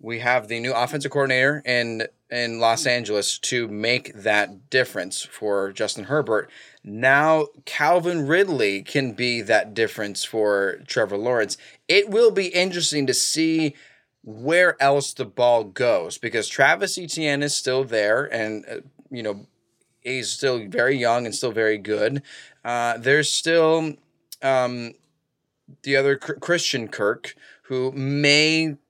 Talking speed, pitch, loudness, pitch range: 140 wpm, 130 Hz, -21 LUFS, 115-150 Hz